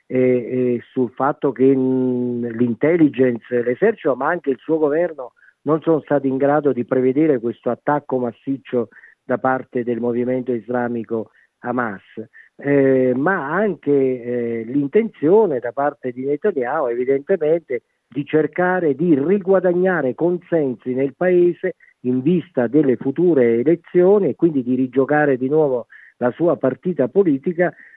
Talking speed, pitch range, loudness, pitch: 130 wpm, 125-165 Hz, -19 LUFS, 135 Hz